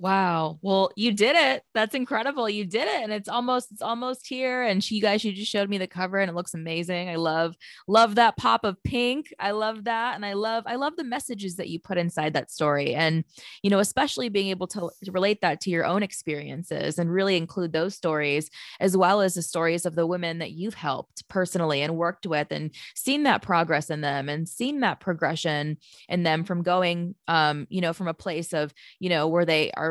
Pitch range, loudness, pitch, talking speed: 165-210 Hz, -25 LUFS, 185 Hz, 225 wpm